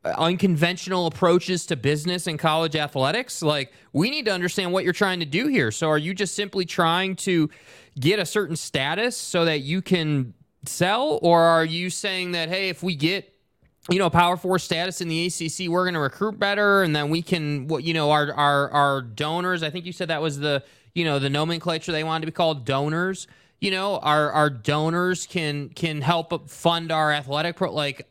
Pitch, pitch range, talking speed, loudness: 165 Hz, 150-180 Hz, 205 wpm, -23 LUFS